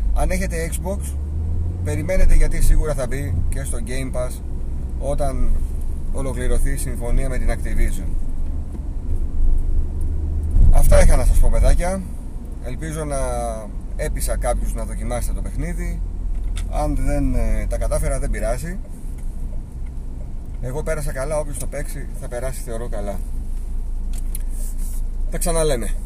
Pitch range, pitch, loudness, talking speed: 70-95 Hz, 80 Hz, -25 LUFS, 115 wpm